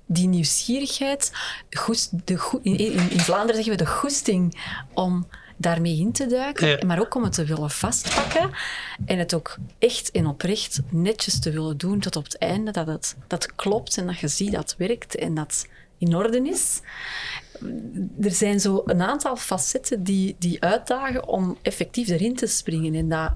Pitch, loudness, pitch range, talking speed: 190 Hz, -24 LUFS, 170-230 Hz, 170 wpm